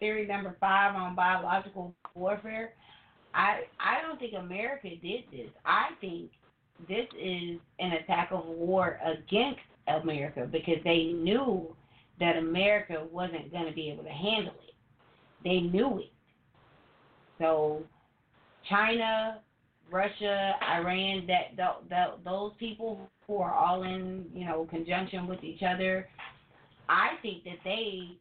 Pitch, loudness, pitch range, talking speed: 180 Hz, -31 LUFS, 165-200 Hz, 130 wpm